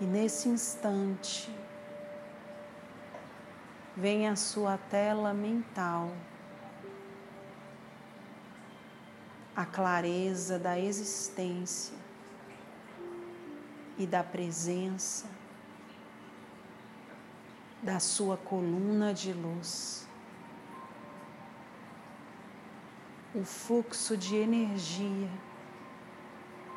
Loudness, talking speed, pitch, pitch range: -34 LUFS, 55 wpm, 195 Hz, 185-210 Hz